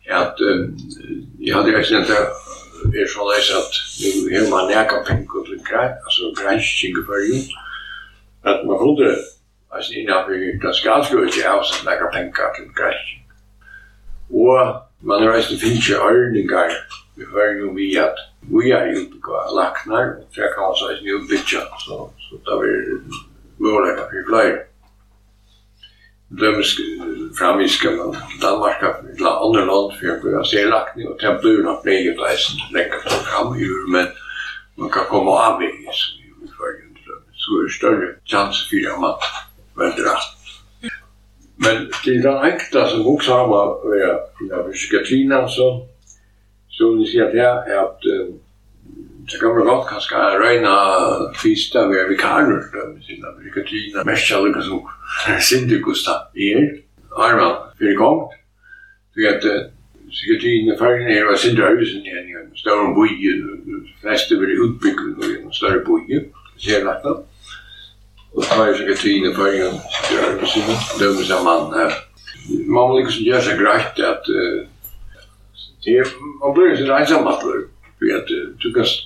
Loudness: -17 LUFS